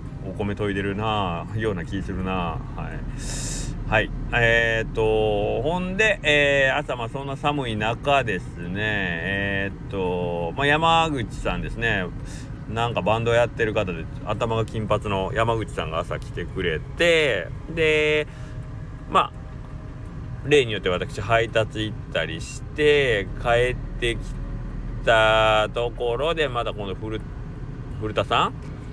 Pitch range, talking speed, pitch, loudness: 105-135 Hz, 240 characters per minute, 115 Hz, -23 LUFS